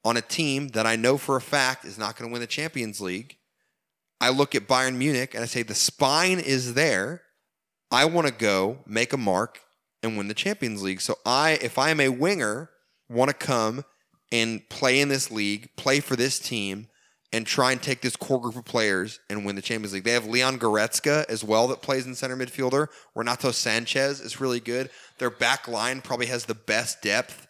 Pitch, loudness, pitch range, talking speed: 125 Hz, -25 LUFS, 115-135 Hz, 215 wpm